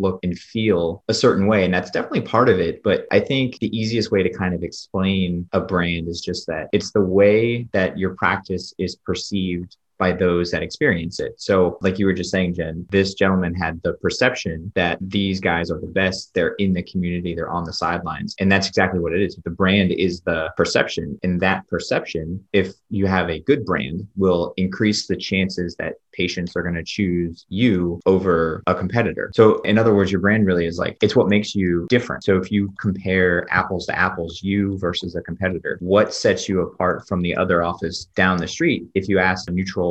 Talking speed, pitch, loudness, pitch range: 210 wpm, 95 Hz, -20 LUFS, 90-95 Hz